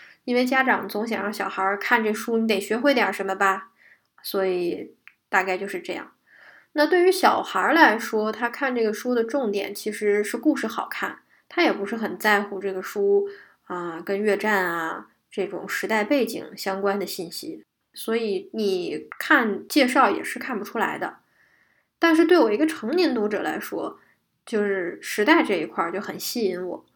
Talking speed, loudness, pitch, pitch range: 255 characters per minute, -23 LUFS, 210 Hz, 195-250 Hz